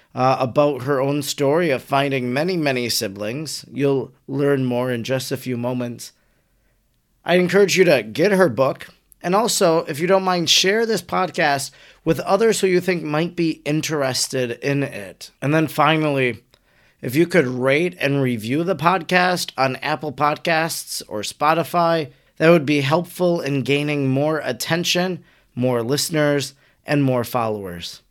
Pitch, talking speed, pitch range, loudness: 145 Hz, 155 wpm, 130-165 Hz, -19 LUFS